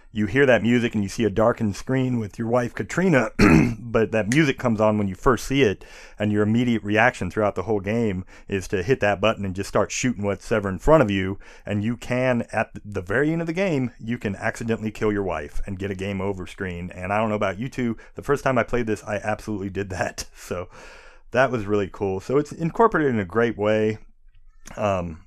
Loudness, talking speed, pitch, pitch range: -23 LUFS, 235 wpm, 110 Hz, 100-120 Hz